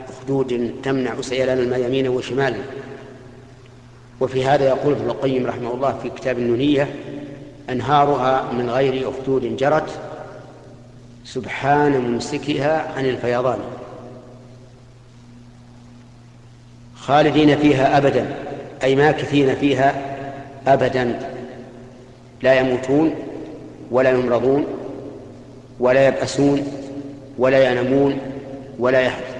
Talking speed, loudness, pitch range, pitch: 80 wpm, -19 LUFS, 125-140 Hz, 130 Hz